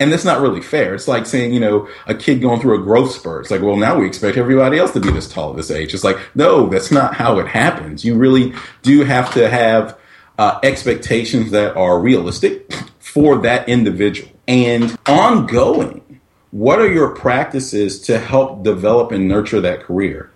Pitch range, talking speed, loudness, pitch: 105-130 Hz, 200 wpm, -14 LUFS, 120 Hz